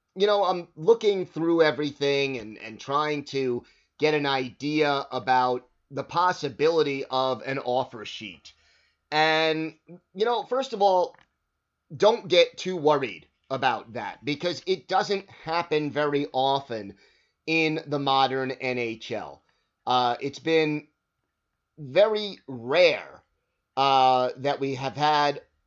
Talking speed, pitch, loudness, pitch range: 120 wpm, 145 Hz, -25 LUFS, 130-170 Hz